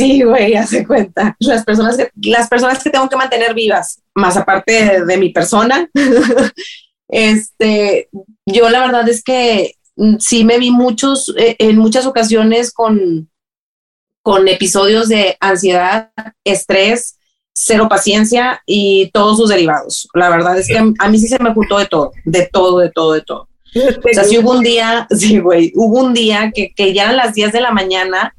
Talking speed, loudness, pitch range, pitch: 180 wpm, -11 LUFS, 195-240 Hz, 220 Hz